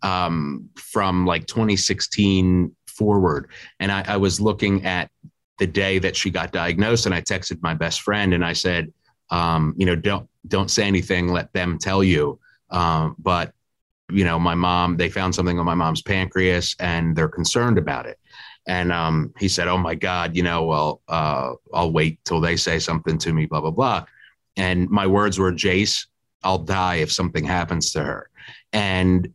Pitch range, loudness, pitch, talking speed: 85-95 Hz, -21 LUFS, 90 Hz, 185 wpm